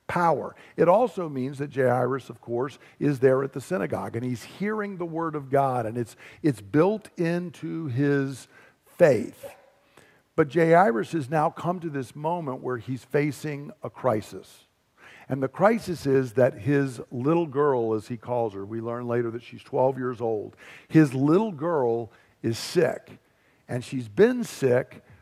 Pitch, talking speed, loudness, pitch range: 135 Hz, 165 wpm, -26 LUFS, 125-160 Hz